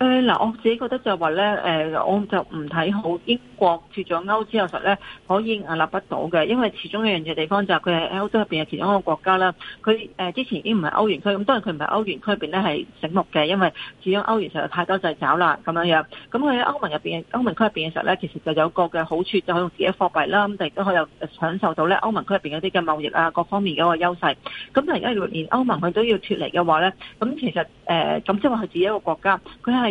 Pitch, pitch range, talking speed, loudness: 190 Hz, 165-215 Hz, 390 characters per minute, -22 LUFS